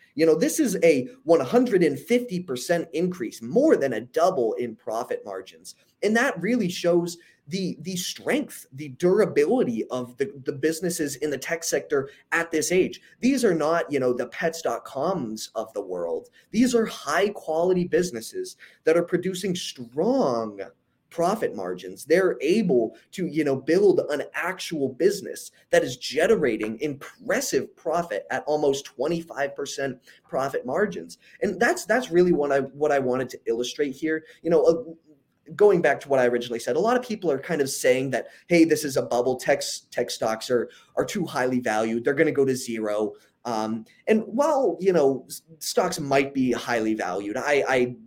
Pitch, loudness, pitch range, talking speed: 160 Hz, -24 LUFS, 135-195 Hz, 170 wpm